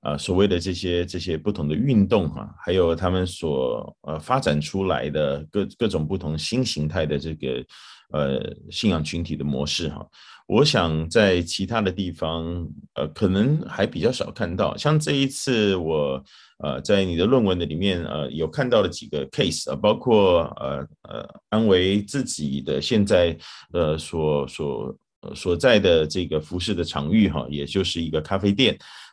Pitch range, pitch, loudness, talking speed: 75-95 Hz, 85 Hz, -23 LUFS, 260 characters per minute